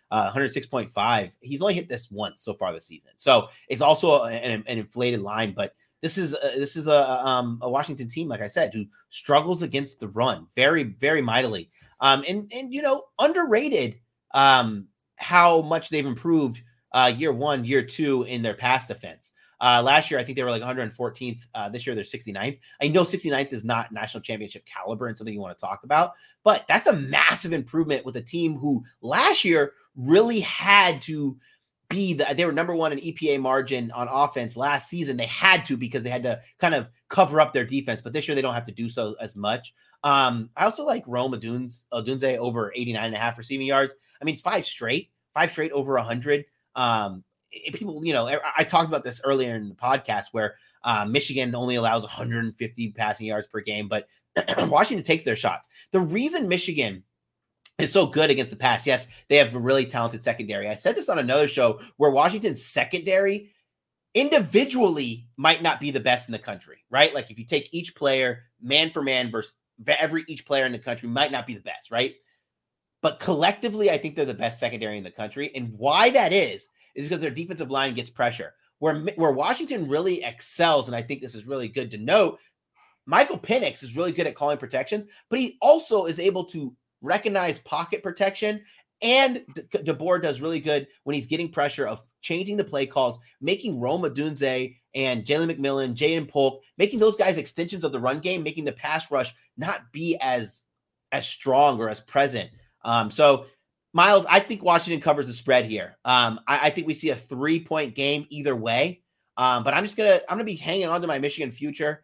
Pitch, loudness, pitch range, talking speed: 140 Hz, -24 LUFS, 120-165 Hz, 205 wpm